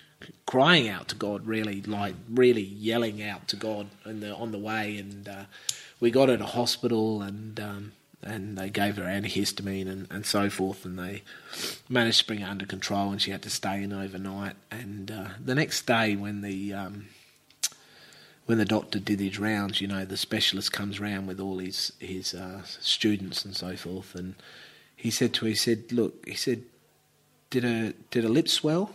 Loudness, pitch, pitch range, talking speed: -28 LUFS, 100 Hz, 95-110 Hz, 195 wpm